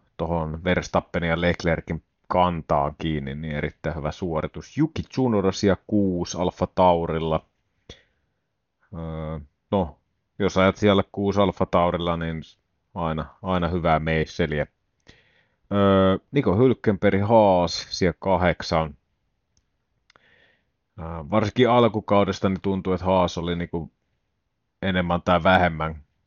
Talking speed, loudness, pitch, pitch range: 105 wpm, -23 LUFS, 90 Hz, 80-95 Hz